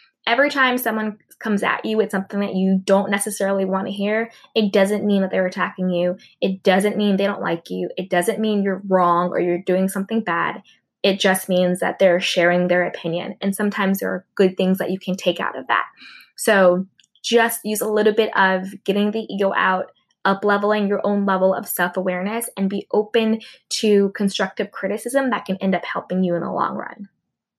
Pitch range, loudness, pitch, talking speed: 185-210 Hz, -20 LUFS, 195 Hz, 205 wpm